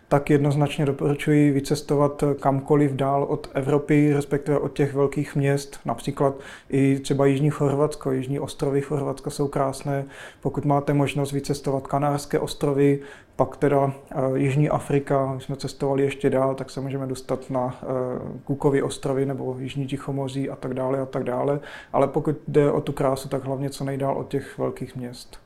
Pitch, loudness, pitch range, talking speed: 140 Hz, -24 LUFS, 135-145 Hz, 160 wpm